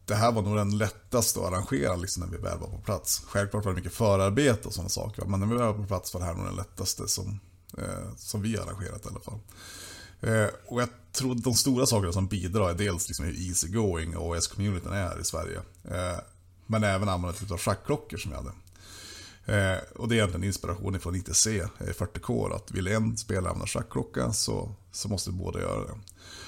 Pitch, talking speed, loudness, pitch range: 100 Hz, 225 wpm, -29 LUFS, 90-110 Hz